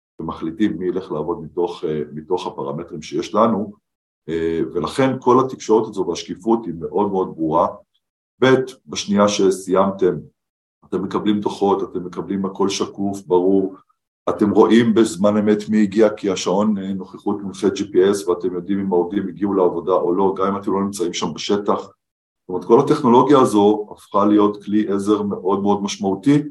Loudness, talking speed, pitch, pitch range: -19 LUFS, 150 wpm, 100 Hz, 95-105 Hz